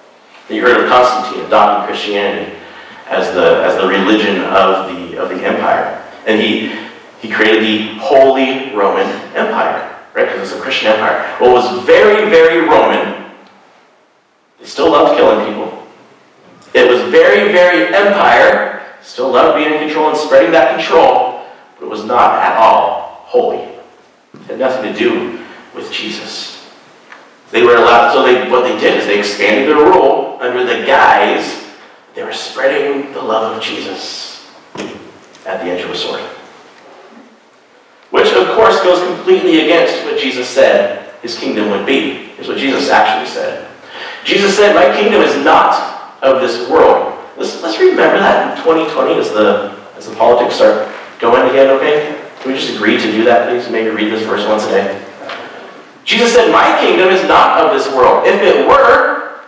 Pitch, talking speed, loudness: 180 Hz, 170 wpm, -11 LUFS